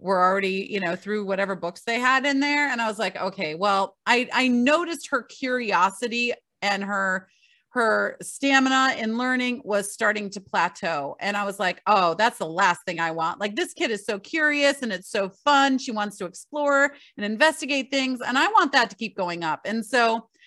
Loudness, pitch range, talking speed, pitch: -23 LUFS, 195-265 Hz, 205 wpm, 225 Hz